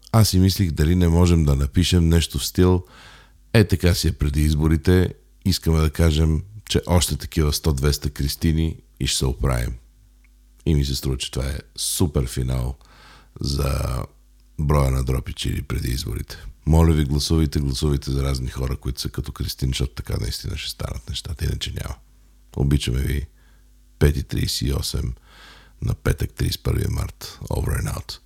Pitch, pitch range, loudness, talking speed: 75 Hz, 65-90 Hz, -22 LUFS, 160 wpm